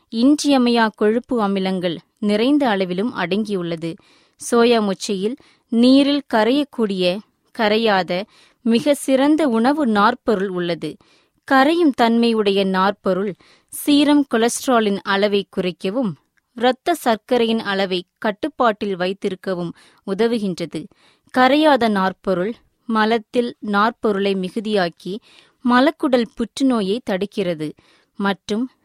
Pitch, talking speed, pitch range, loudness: 220 Hz, 80 wpm, 195-250 Hz, -19 LUFS